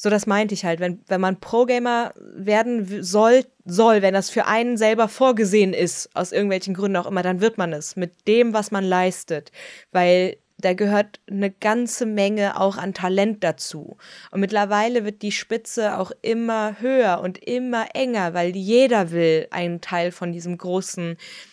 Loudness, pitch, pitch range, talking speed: -21 LUFS, 200 Hz, 180-225 Hz, 175 wpm